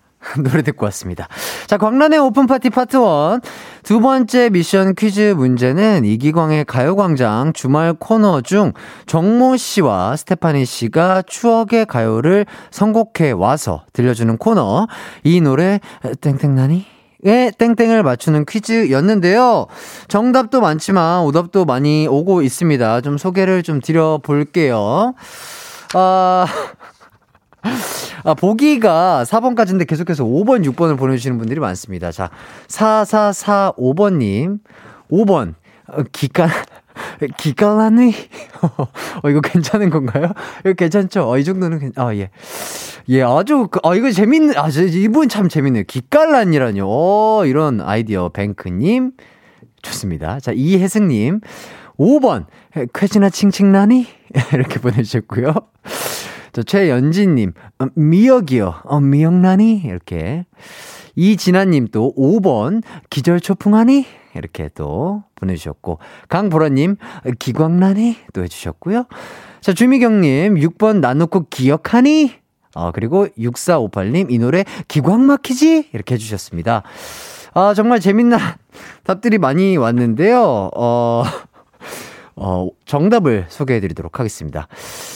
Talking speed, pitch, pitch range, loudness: 250 characters per minute, 175 Hz, 130-215 Hz, -15 LUFS